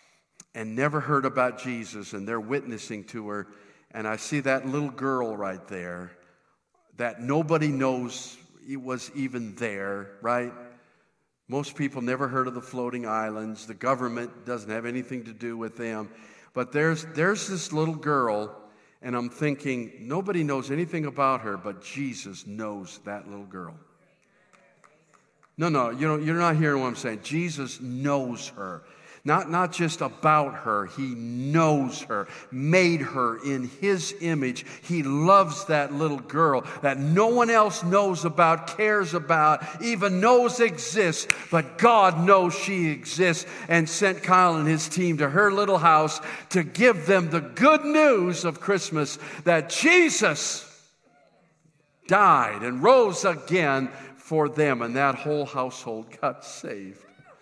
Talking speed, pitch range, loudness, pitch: 150 wpm, 120-170 Hz, -24 LUFS, 140 Hz